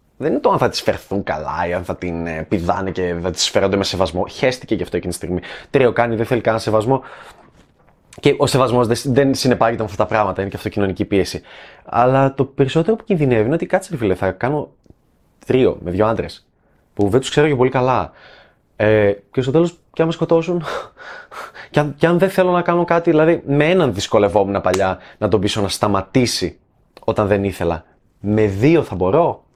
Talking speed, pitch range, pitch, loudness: 205 wpm, 95-145 Hz, 115 Hz, -18 LUFS